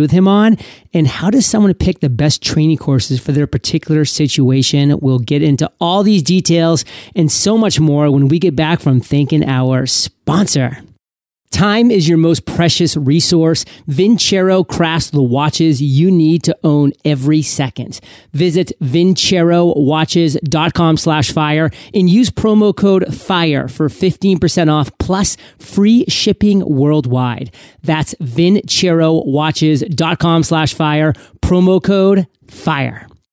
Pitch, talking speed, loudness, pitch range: 155 Hz, 130 wpm, -13 LUFS, 145-180 Hz